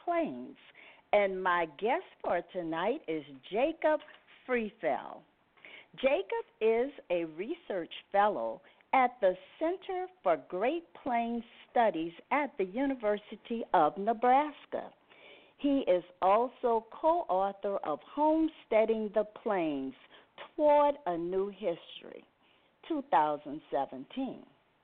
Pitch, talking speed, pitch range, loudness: 240 Hz, 95 wpm, 195-300 Hz, -32 LUFS